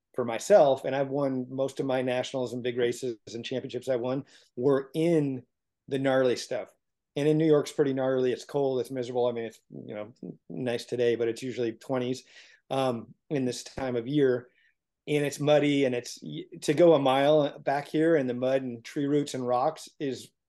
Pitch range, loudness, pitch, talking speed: 125-145 Hz, -28 LUFS, 130 Hz, 200 wpm